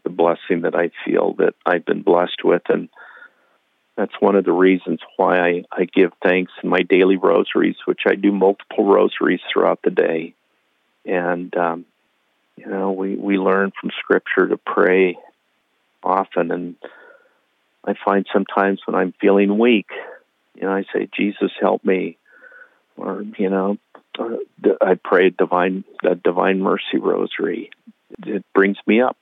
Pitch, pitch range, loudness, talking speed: 95 Hz, 90-100 Hz, -19 LUFS, 155 wpm